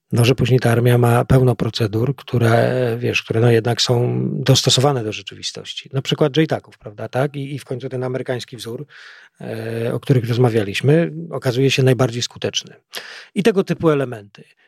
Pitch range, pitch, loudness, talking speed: 115-135 Hz, 125 Hz, -18 LUFS, 165 wpm